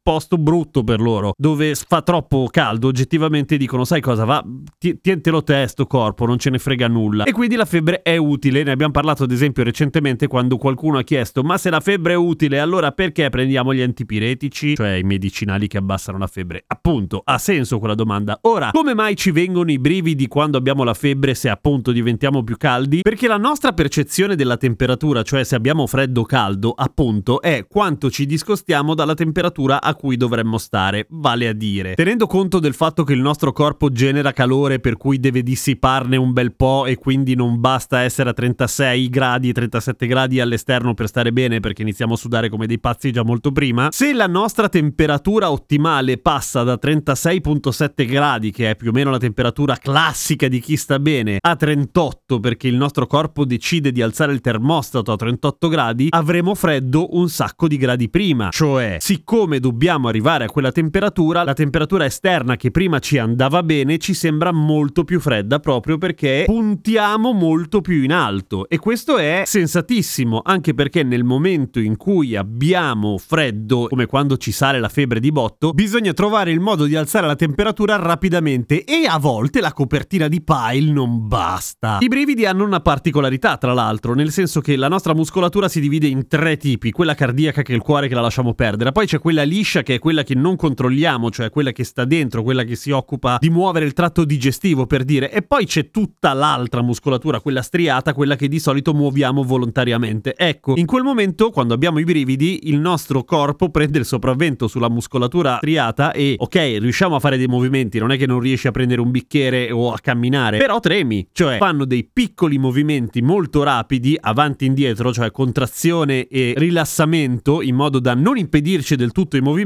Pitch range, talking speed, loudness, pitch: 125-165 Hz, 190 wpm, -17 LUFS, 140 Hz